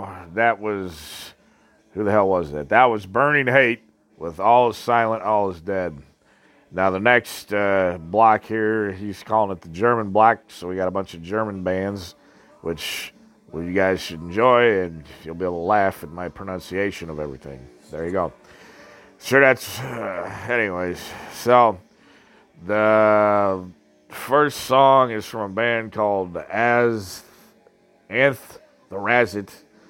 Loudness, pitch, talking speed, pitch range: -20 LUFS, 100 Hz, 155 wpm, 90-115 Hz